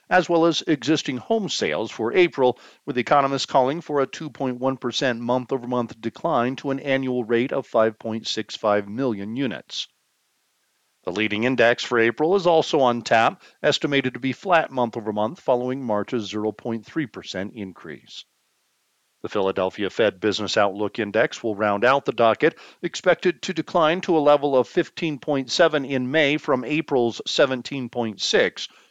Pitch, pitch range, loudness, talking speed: 130 Hz, 115-155 Hz, -22 LUFS, 135 wpm